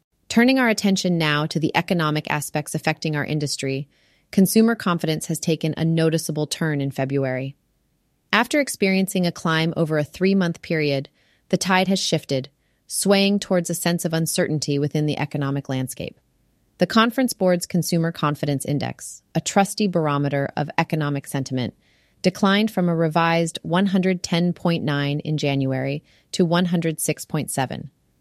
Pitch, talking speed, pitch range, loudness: 165 Hz, 135 wpm, 145-185 Hz, -22 LUFS